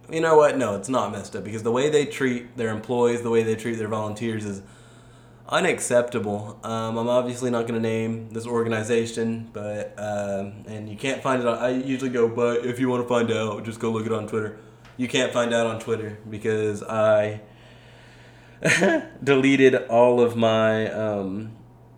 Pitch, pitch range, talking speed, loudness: 115 Hz, 110-120 Hz, 190 wpm, -23 LUFS